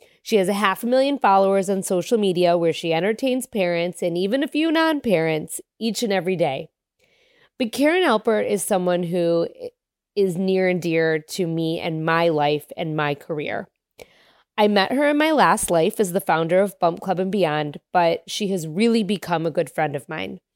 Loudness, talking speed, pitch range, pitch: -21 LUFS, 195 wpm, 170-230 Hz, 190 Hz